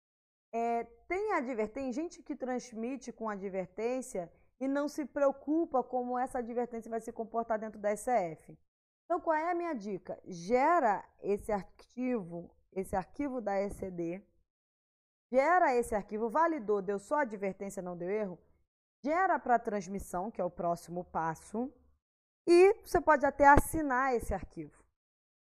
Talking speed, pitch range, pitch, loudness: 140 wpm, 200-285 Hz, 235 Hz, -33 LUFS